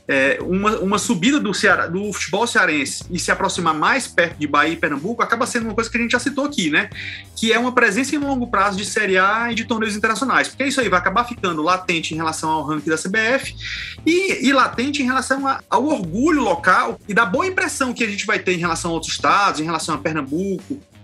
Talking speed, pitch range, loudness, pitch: 235 wpm, 175-255 Hz, -19 LUFS, 215 Hz